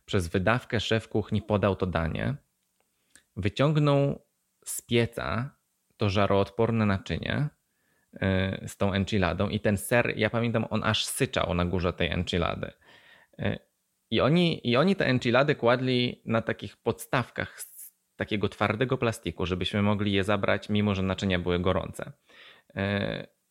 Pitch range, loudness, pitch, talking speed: 95-115 Hz, -27 LUFS, 105 Hz, 130 wpm